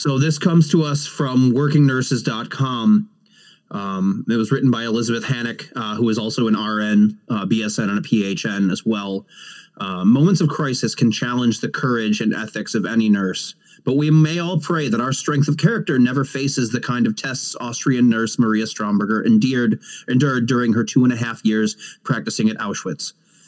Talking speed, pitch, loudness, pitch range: 185 wpm, 125 Hz, -19 LUFS, 110-145 Hz